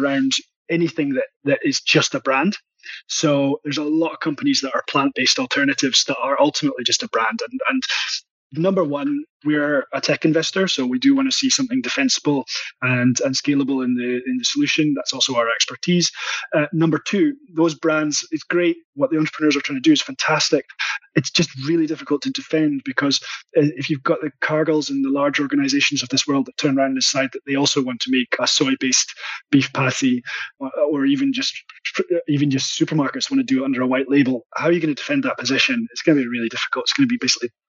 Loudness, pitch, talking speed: -19 LUFS, 160 Hz, 220 wpm